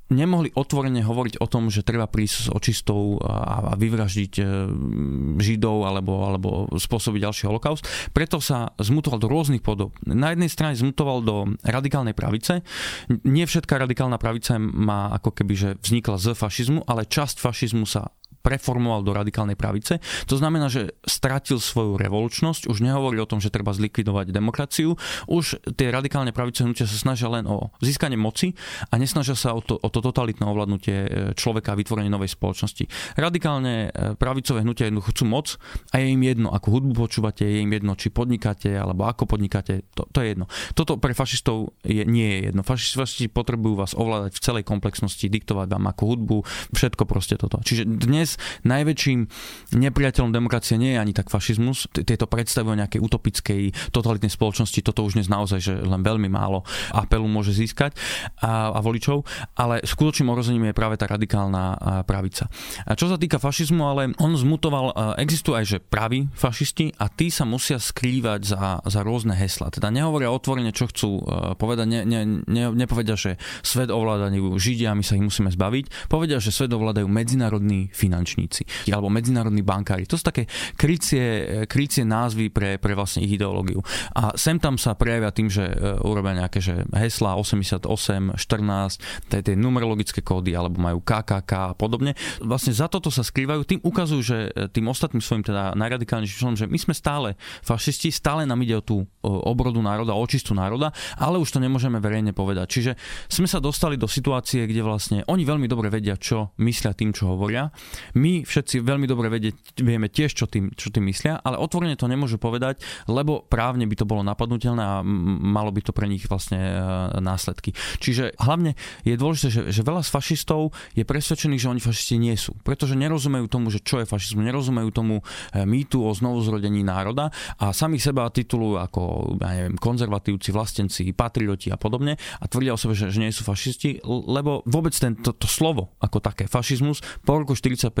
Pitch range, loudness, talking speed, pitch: 105-130 Hz, -23 LUFS, 175 wpm, 115 Hz